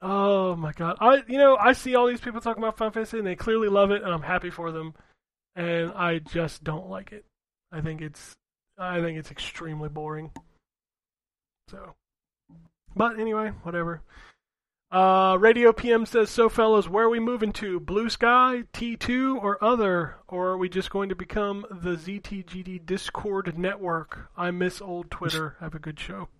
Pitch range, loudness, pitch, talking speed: 170-220 Hz, -25 LUFS, 185 Hz, 185 wpm